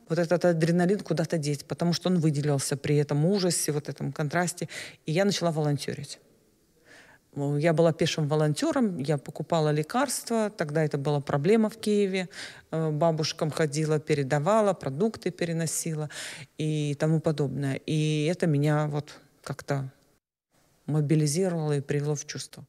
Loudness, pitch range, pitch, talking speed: -27 LUFS, 150-175 Hz, 155 Hz, 130 wpm